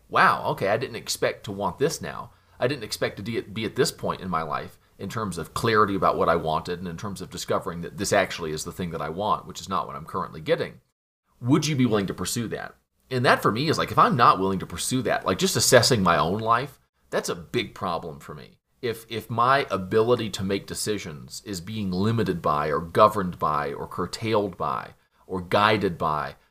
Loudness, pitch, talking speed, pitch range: -25 LUFS, 100 Hz, 230 wpm, 85-110 Hz